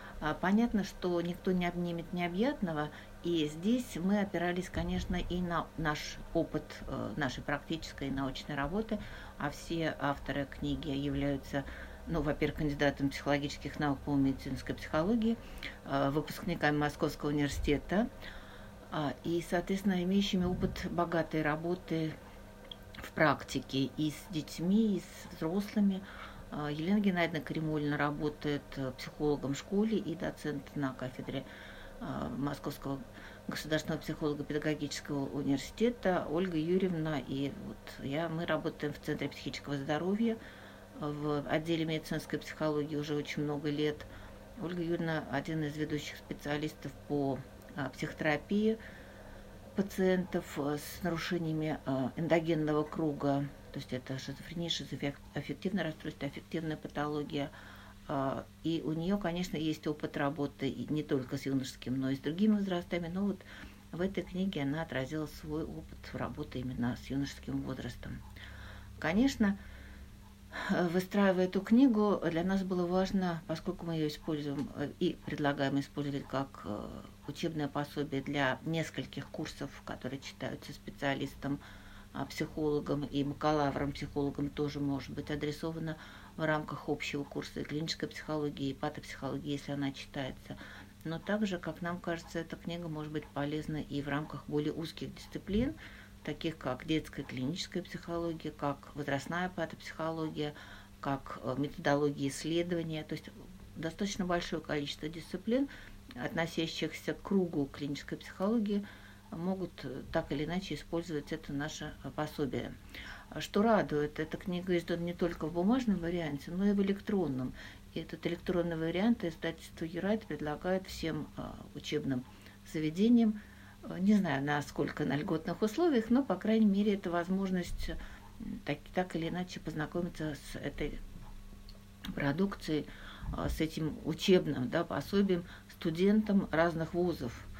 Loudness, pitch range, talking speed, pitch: -35 LUFS, 140-175 Hz, 120 wpm, 155 Hz